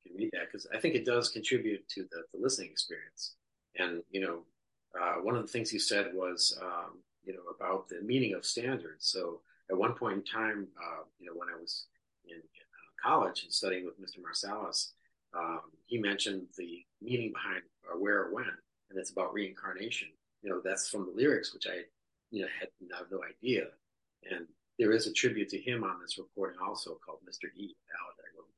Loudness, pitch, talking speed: -35 LUFS, 110 Hz, 200 wpm